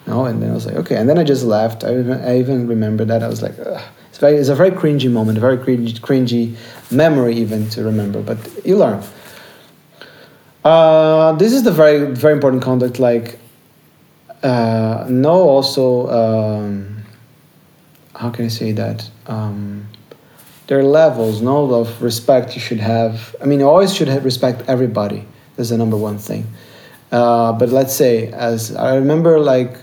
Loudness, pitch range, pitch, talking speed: -15 LUFS, 115-140 Hz, 125 Hz, 180 wpm